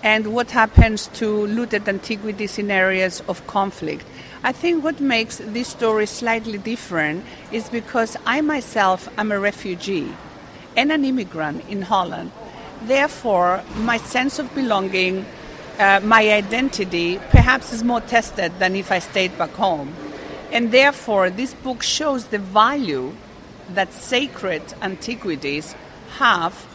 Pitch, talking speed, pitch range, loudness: 220 Hz, 130 wpm, 195-240 Hz, -20 LUFS